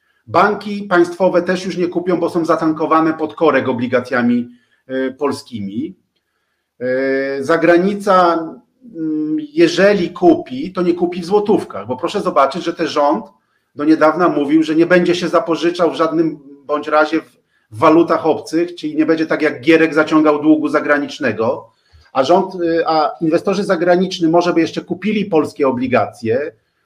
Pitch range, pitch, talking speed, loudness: 150-175 Hz, 165 Hz, 150 wpm, -15 LUFS